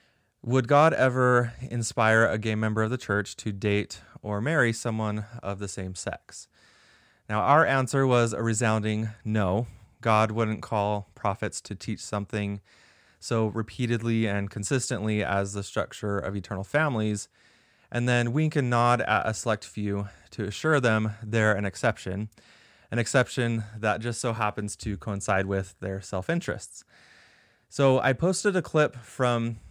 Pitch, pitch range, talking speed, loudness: 110 Hz, 105-120 Hz, 155 wpm, -27 LUFS